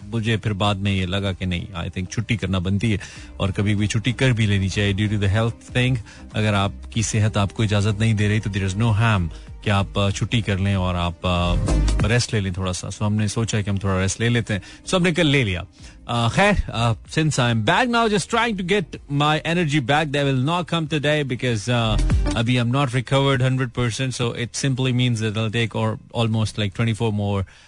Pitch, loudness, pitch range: 110 Hz, -21 LUFS, 100-125 Hz